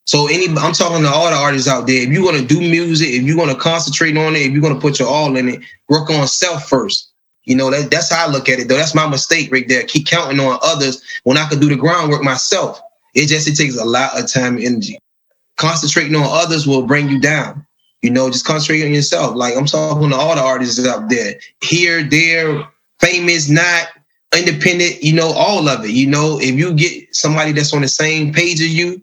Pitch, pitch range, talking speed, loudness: 150 Hz, 135-165 Hz, 240 wpm, -13 LUFS